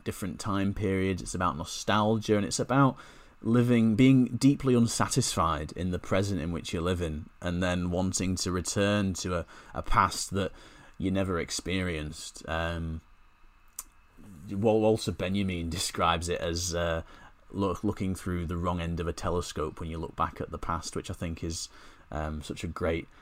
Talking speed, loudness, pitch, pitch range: 165 wpm, -29 LUFS, 90 Hz, 85-100 Hz